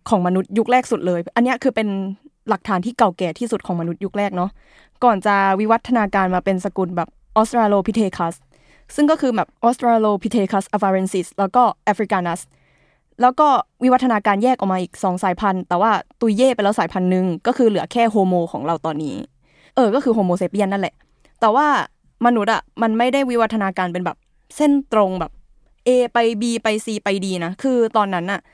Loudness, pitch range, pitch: -19 LUFS, 185-235 Hz, 210 Hz